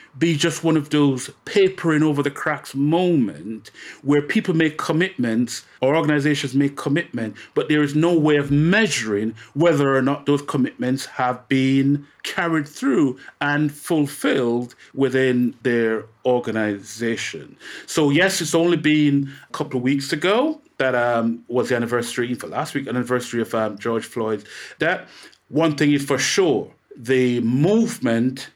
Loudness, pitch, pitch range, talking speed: -20 LUFS, 140 Hz, 120-155 Hz, 145 wpm